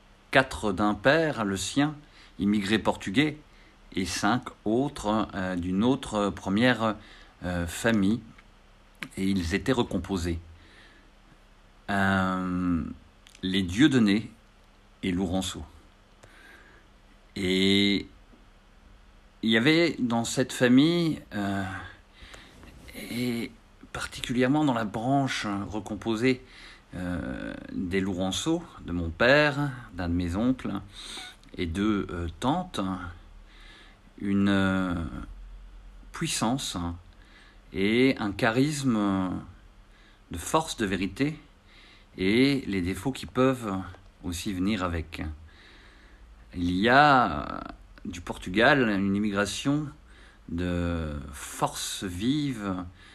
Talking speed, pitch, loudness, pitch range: 95 wpm, 100 Hz, -27 LUFS, 95-120 Hz